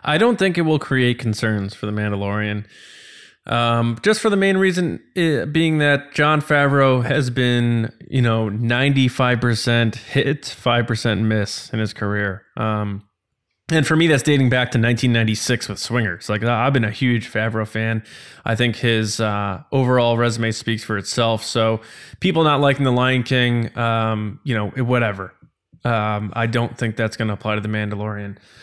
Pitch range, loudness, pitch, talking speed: 110-130 Hz, -19 LUFS, 115 Hz, 170 wpm